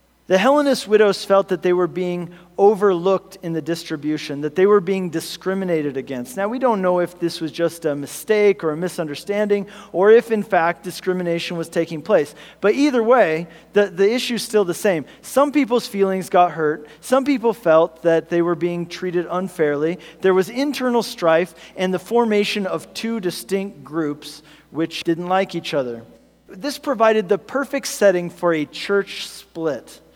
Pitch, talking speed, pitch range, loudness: 180 Hz, 175 wpm, 165-205 Hz, -20 LUFS